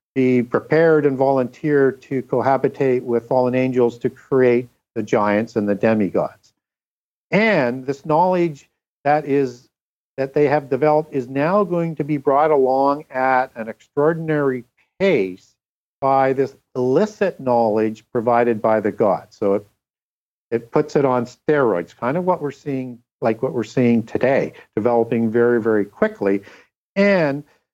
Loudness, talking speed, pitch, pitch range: -19 LUFS, 145 wpm, 130 Hz, 120-145 Hz